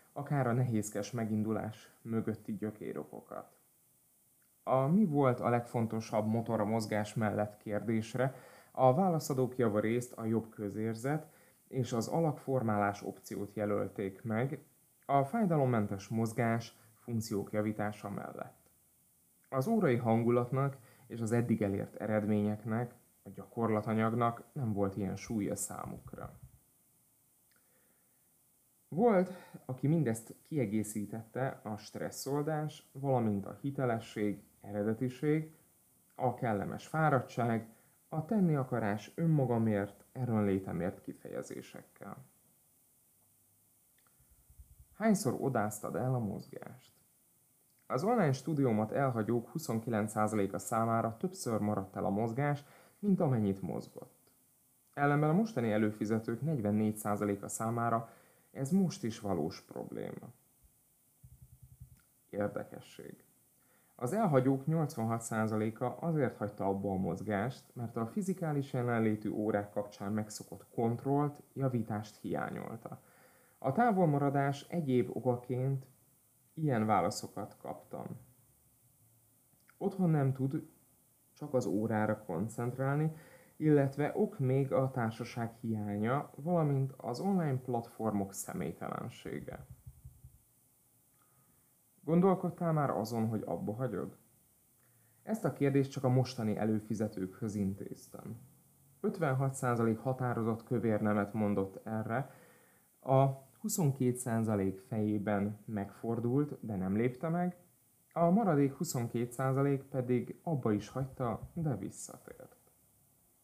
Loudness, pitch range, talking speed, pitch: -34 LUFS, 110-140 Hz, 95 wpm, 120 Hz